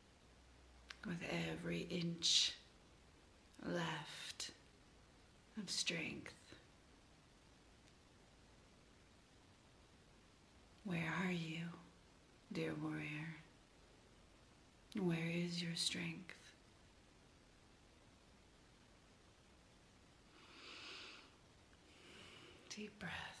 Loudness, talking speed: -44 LUFS, 45 wpm